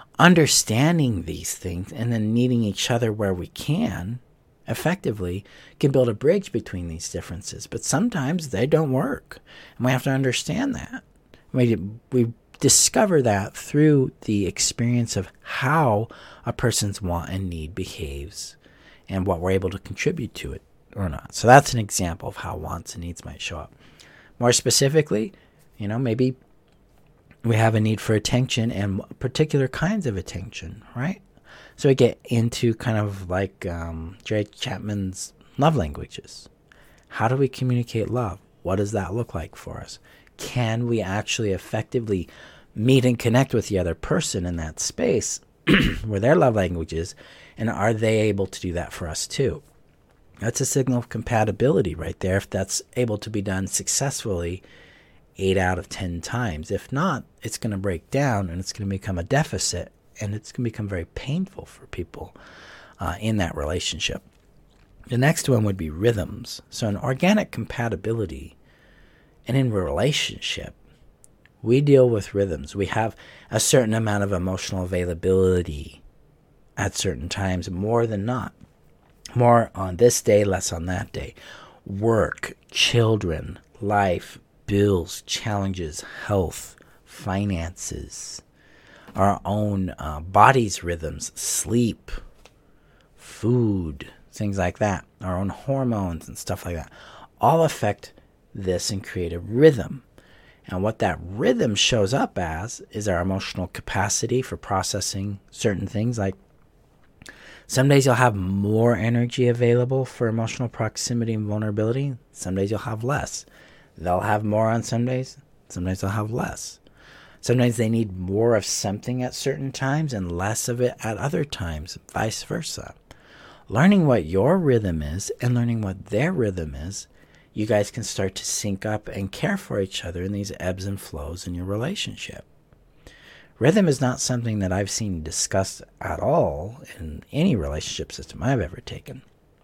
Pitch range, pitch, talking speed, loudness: 95-120 Hz, 105 Hz, 155 wpm, -23 LUFS